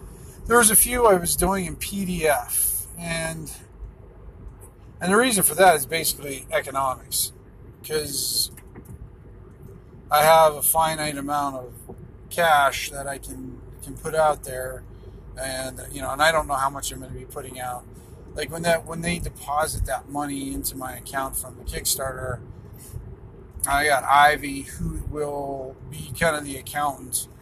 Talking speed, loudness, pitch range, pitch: 155 wpm, -22 LUFS, 125-155 Hz, 135 Hz